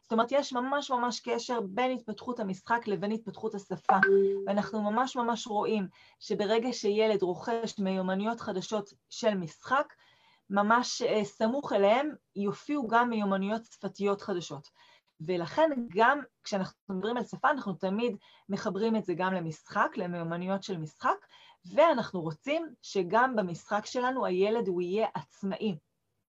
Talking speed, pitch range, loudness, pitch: 130 wpm, 195-235 Hz, -30 LUFS, 210 Hz